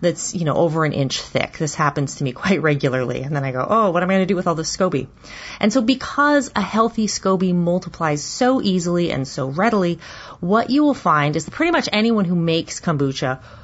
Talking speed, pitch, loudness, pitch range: 230 wpm, 175 Hz, -19 LUFS, 145-210 Hz